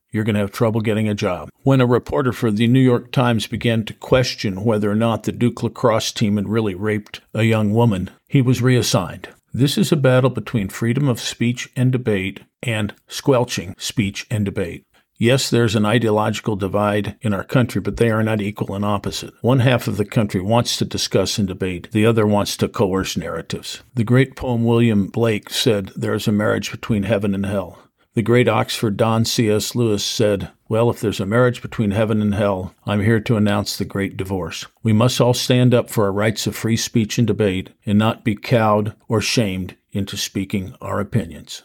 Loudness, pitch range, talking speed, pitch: -19 LUFS, 105-120 Hz, 205 wpm, 110 Hz